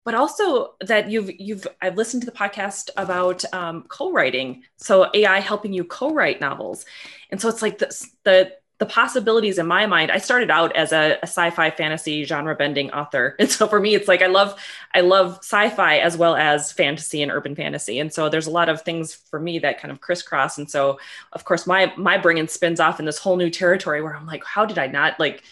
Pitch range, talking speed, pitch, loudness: 155-205 Hz, 220 wpm, 180 Hz, -20 LUFS